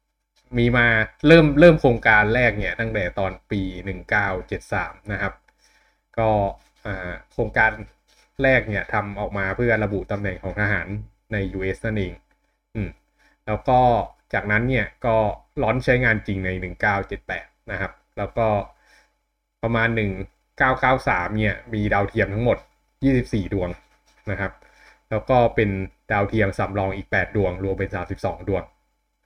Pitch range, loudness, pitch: 95-115 Hz, -22 LUFS, 105 Hz